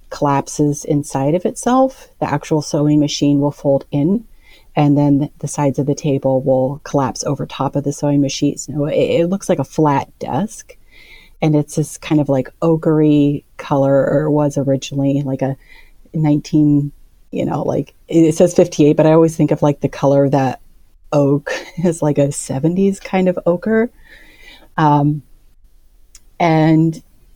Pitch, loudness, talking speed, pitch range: 145 Hz, -16 LUFS, 160 wpm, 140-160 Hz